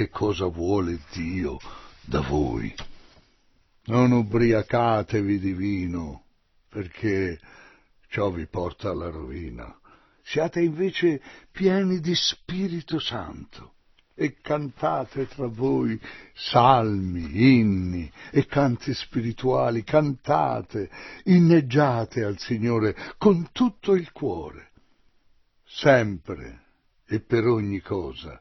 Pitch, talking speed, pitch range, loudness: 115 Hz, 90 wpm, 95-145 Hz, -24 LUFS